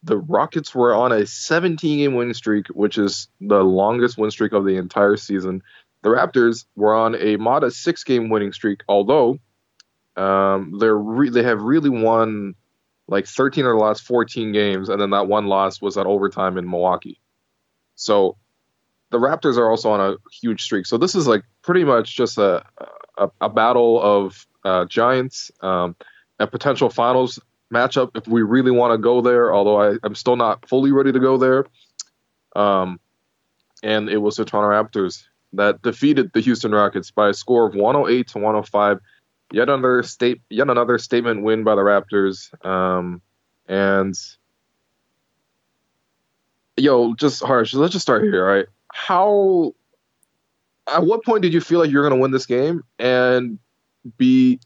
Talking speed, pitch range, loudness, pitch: 170 wpm, 100-125 Hz, -18 LUFS, 110 Hz